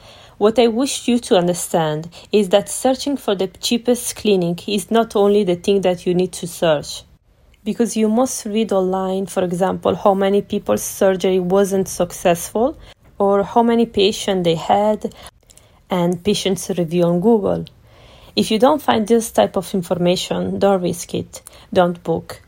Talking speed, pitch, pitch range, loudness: 160 wpm, 195 Hz, 180-220 Hz, -18 LUFS